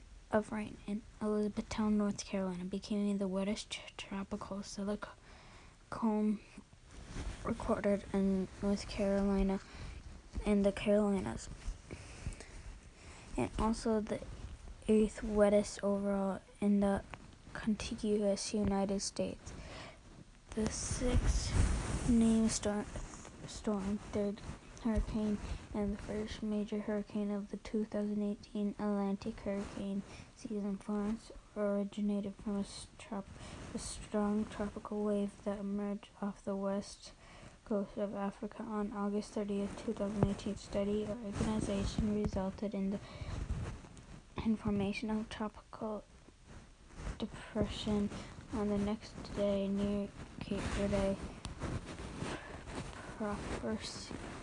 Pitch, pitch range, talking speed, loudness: 205 Hz, 200-210 Hz, 95 wpm, -37 LUFS